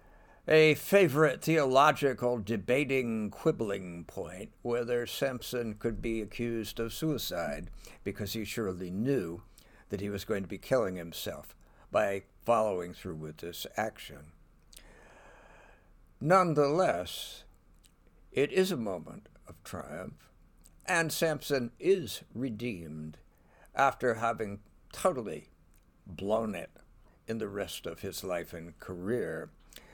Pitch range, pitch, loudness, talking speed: 90-135 Hz, 110 Hz, -31 LUFS, 110 wpm